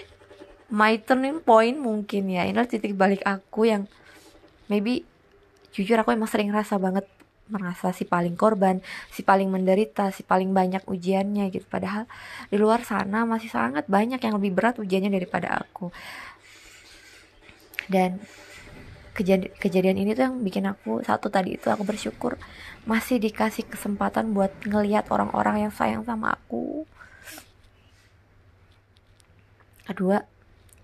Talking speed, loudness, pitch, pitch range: 130 wpm, -25 LUFS, 200 Hz, 185-220 Hz